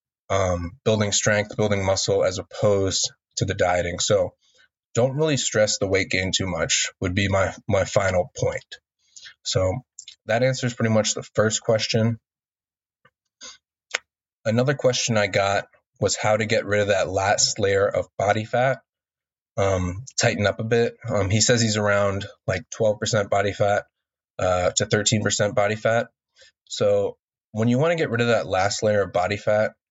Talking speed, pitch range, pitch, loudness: 165 wpm, 100-115 Hz, 105 Hz, -22 LUFS